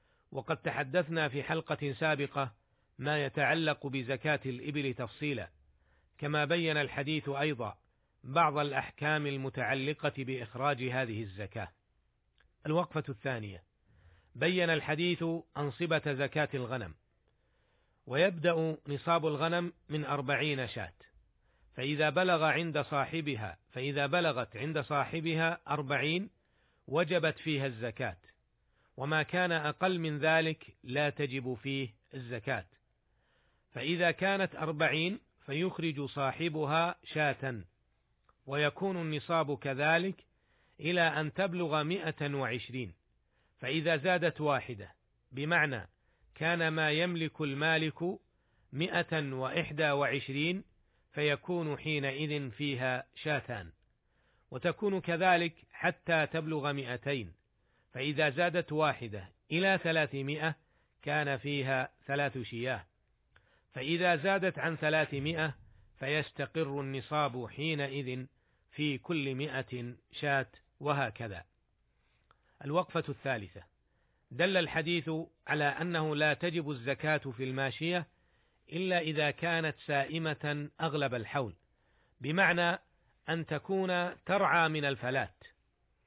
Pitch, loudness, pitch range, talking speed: 145 Hz, -33 LUFS, 130-160 Hz, 90 wpm